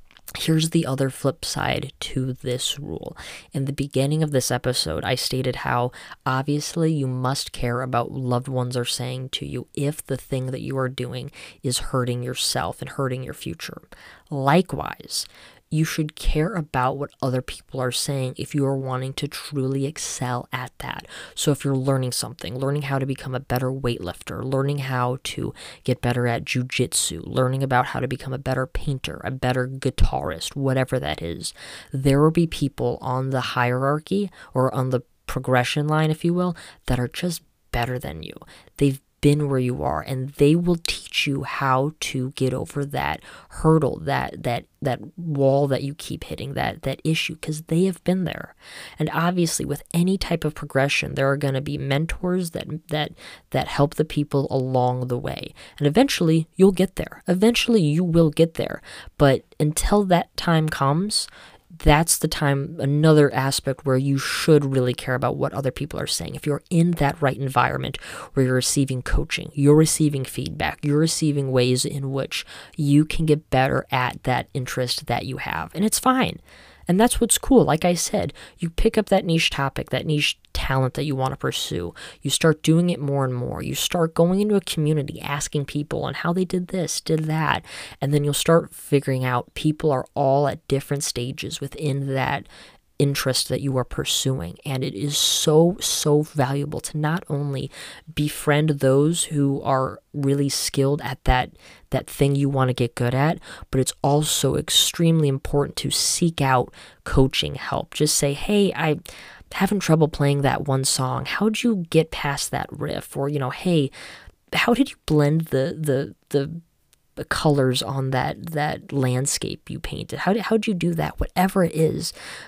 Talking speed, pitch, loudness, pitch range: 180 wpm, 140 Hz, -23 LUFS, 130-155 Hz